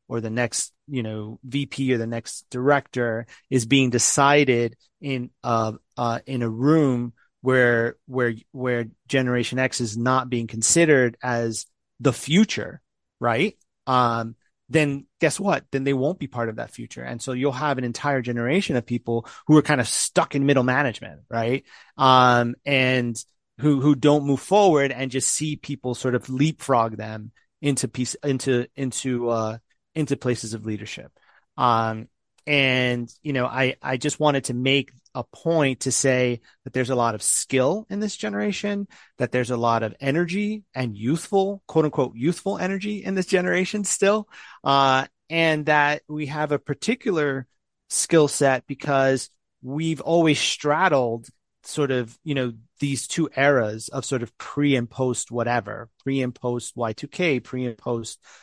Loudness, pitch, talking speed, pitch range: -23 LUFS, 130 Hz, 165 wpm, 120-150 Hz